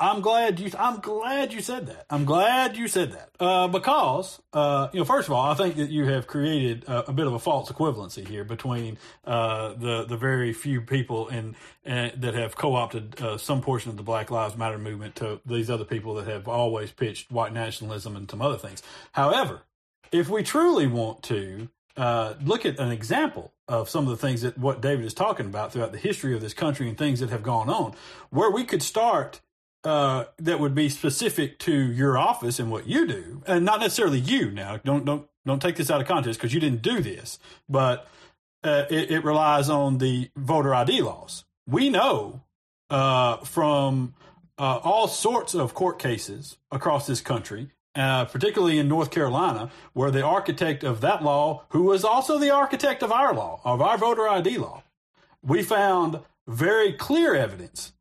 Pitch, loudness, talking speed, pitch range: 135 Hz, -25 LUFS, 195 wpm, 115-160 Hz